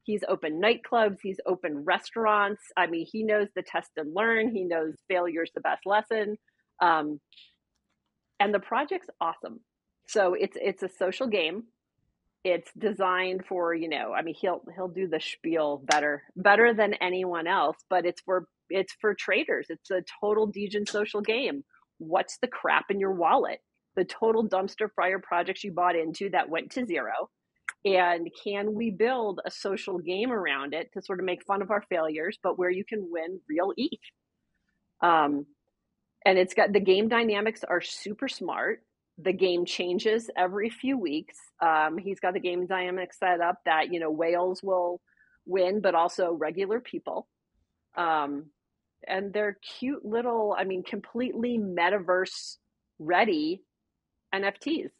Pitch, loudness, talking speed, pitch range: 190 Hz, -28 LUFS, 160 wpm, 175-210 Hz